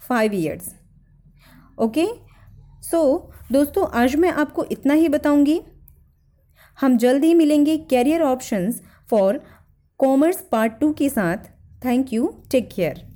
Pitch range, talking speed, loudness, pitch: 235-310 Hz, 125 wpm, -20 LUFS, 280 Hz